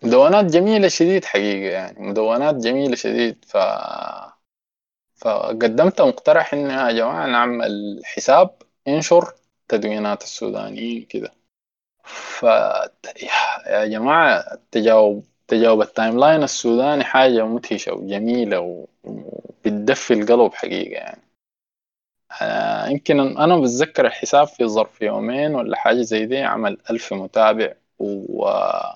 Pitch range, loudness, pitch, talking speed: 110-140 Hz, -18 LUFS, 120 Hz, 110 wpm